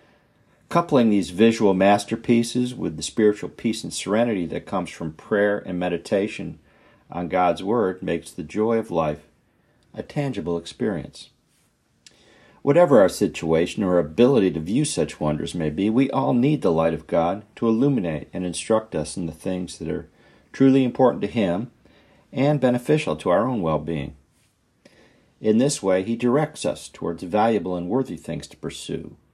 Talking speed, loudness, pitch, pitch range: 165 wpm, -22 LUFS, 100 Hz, 85-120 Hz